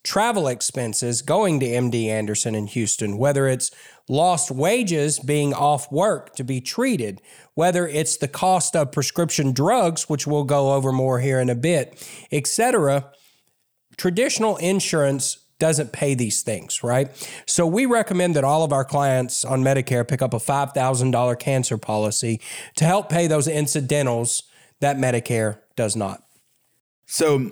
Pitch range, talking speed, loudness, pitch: 125-160 Hz, 150 wpm, -21 LUFS, 140 Hz